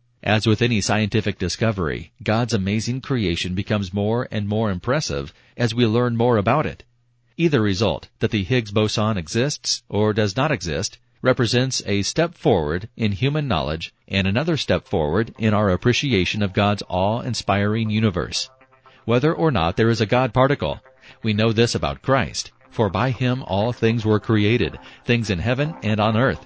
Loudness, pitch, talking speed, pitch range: -21 LUFS, 110 Hz, 170 wpm, 100-125 Hz